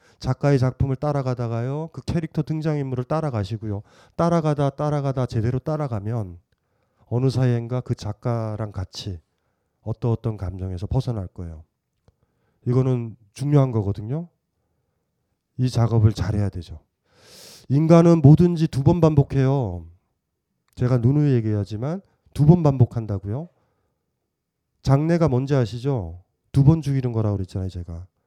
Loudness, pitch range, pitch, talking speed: -22 LUFS, 105-140 Hz, 125 Hz, 295 characters per minute